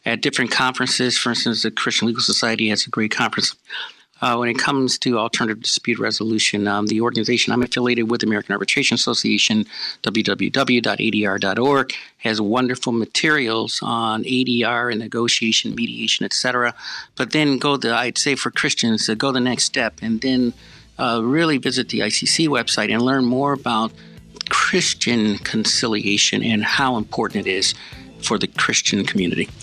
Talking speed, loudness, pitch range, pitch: 155 wpm, -19 LUFS, 110-125 Hz, 120 Hz